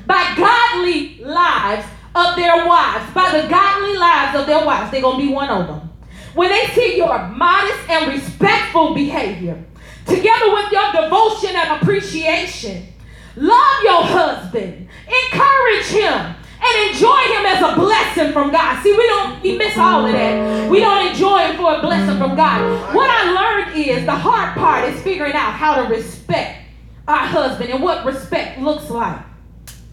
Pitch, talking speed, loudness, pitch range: 345 Hz, 165 wpm, -15 LUFS, 300-405 Hz